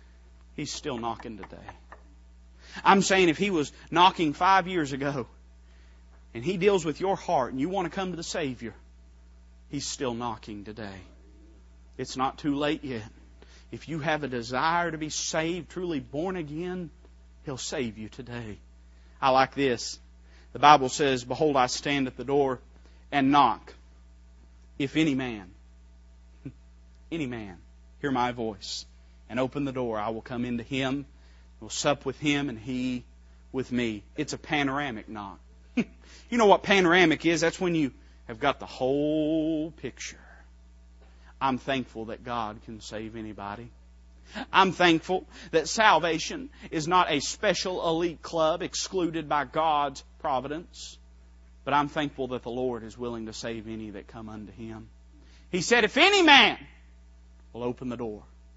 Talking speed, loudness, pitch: 155 wpm, -26 LUFS, 120 Hz